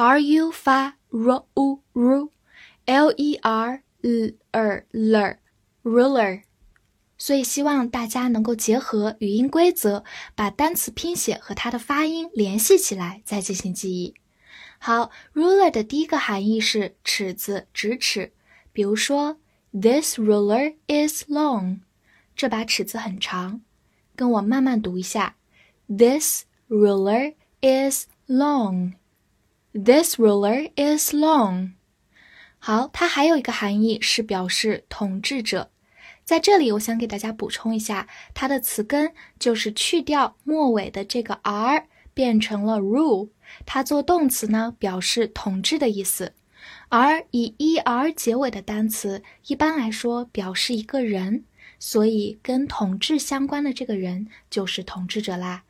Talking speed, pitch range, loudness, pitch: 245 characters per minute, 205-275 Hz, -22 LUFS, 230 Hz